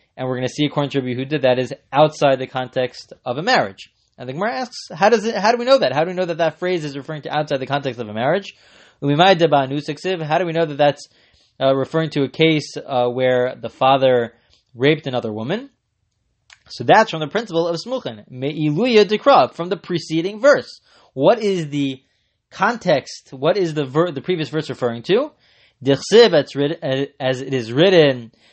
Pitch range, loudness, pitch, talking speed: 130-175 Hz, -18 LUFS, 145 Hz, 200 wpm